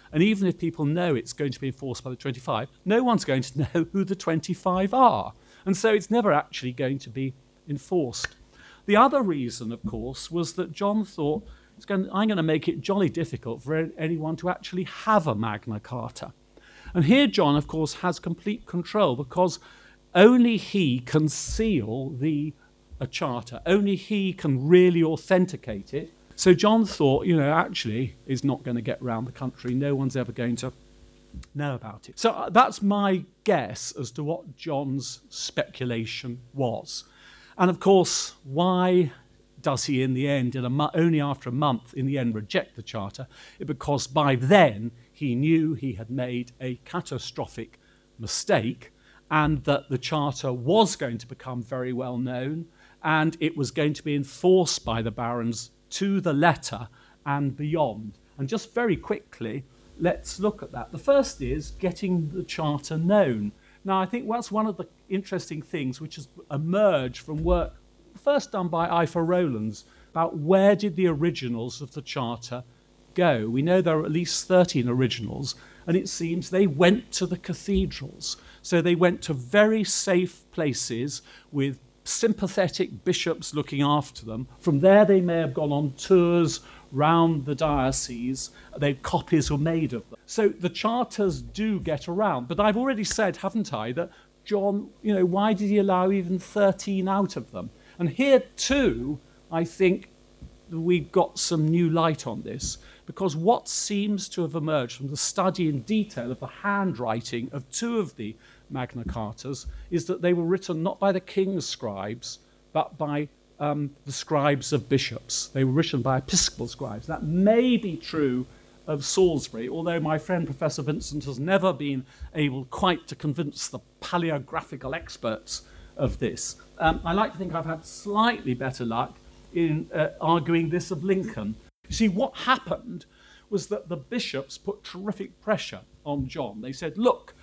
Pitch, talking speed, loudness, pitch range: 155 Hz, 170 wpm, -25 LUFS, 130-185 Hz